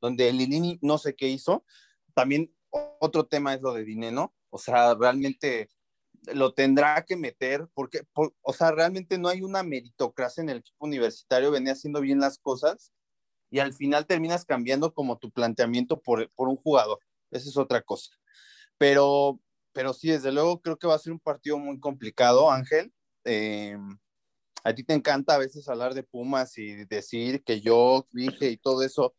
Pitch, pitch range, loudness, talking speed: 140 Hz, 125-160 Hz, -26 LUFS, 180 wpm